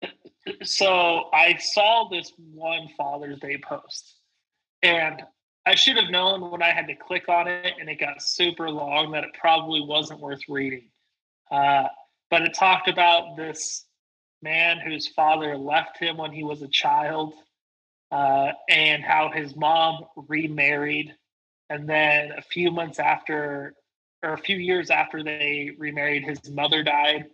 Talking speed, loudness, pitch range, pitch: 150 wpm, -22 LUFS, 145-170 Hz, 155 Hz